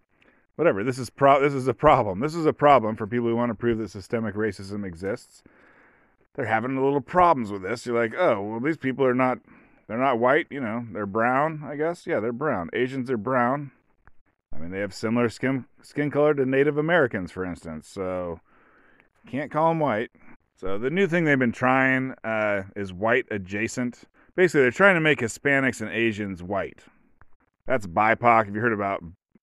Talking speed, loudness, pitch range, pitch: 195 wpm, -24 LUFS, 105-140 Hz, 120 Hz